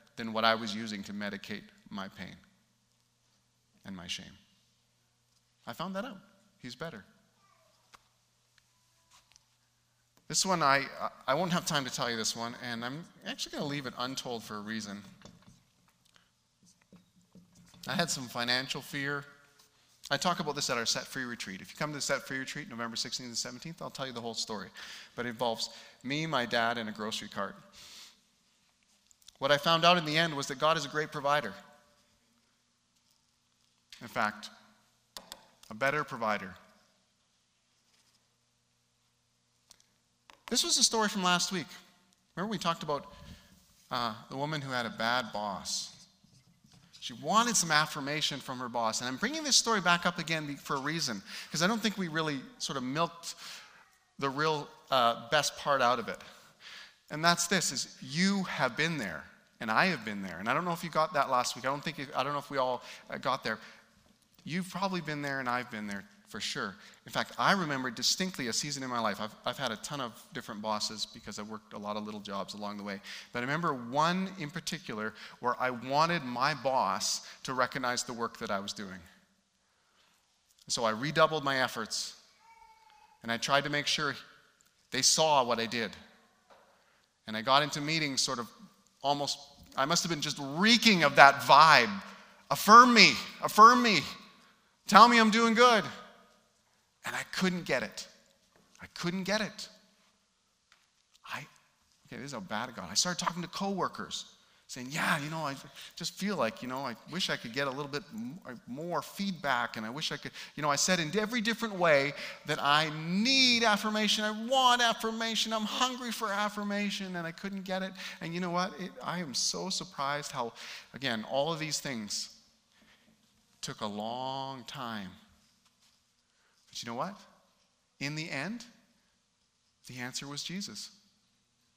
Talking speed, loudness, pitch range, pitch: 180 wpm, -30 LUFS, 120-185 Hz, 145 Hz